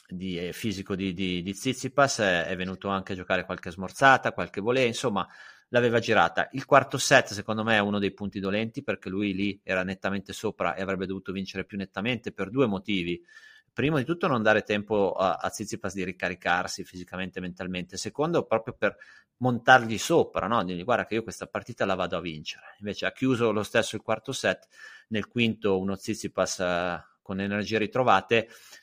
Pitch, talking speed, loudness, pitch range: 100 Hz, 185 wpm, -27 LUFS, 95-115 Hz